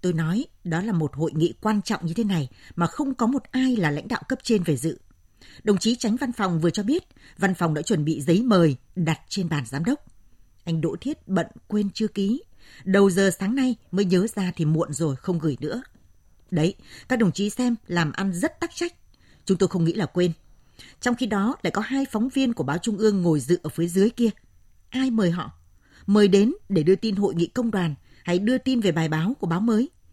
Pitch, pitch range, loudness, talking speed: 195 Hz, 165-230 Hz, -24 LUFS, 235 wpm